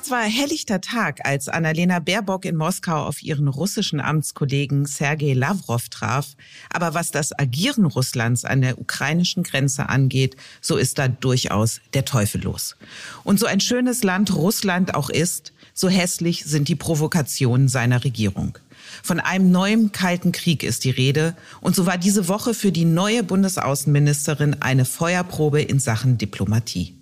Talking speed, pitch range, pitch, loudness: 155 wpm, 135-185 Hz, 155 Hz, -21 LUFS